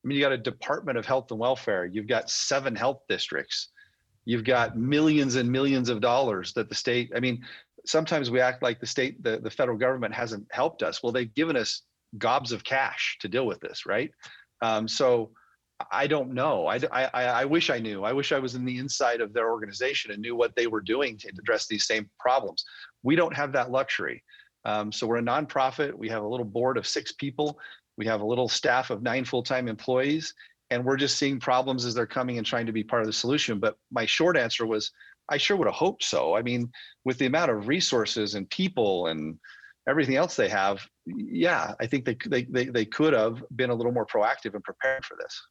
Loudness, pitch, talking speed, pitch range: -27 LUFS, 125 Hz, 225 wpm, 115-135 Hz